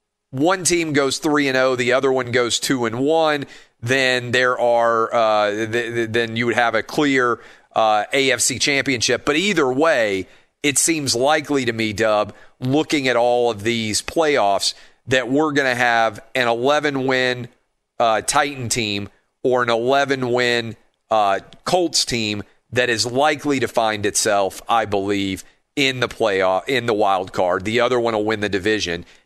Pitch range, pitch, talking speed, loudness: 110-135 Hz, 125 Hz, 170 wpm, -19 LUFS